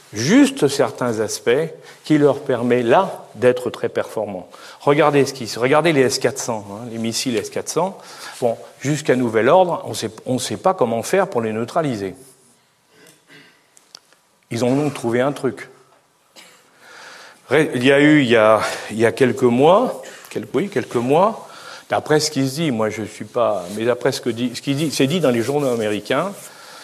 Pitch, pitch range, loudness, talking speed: 125 Hz, 115-145 Hz, -18 LUFS, 180 wpm